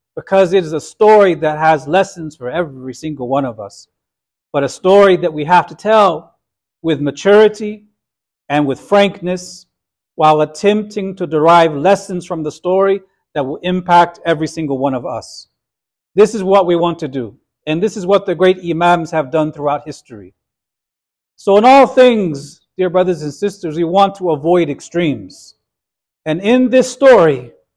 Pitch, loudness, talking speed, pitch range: 175 Hz, -13 LUFS, 170 wpm, 150-195 Hz